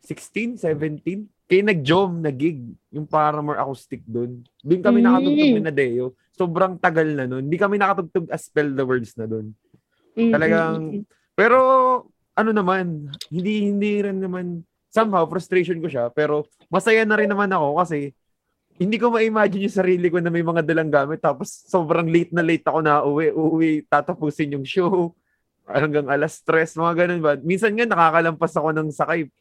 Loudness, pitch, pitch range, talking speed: -20 LUFS, 170 Hz, 150-195 Hz, 165 wpm